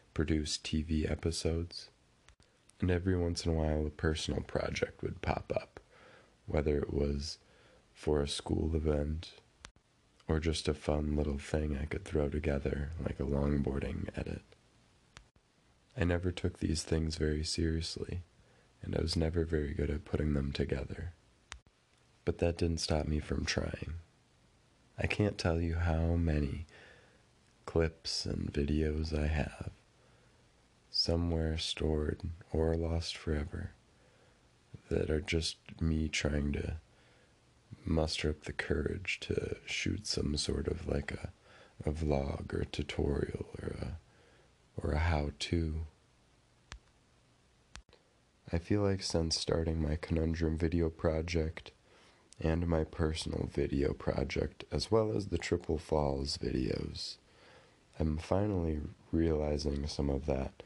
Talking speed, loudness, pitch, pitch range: 130 wpm, -35 LUFS, 80 Hz, 75-90 Hz